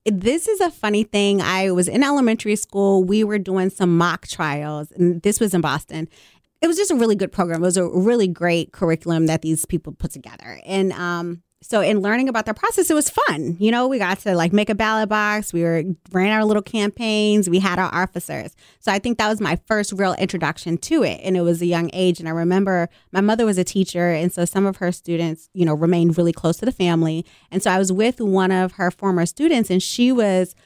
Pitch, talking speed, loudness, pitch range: 185 Hz, 240 wpm, -19 LUFS, 170-210 Hz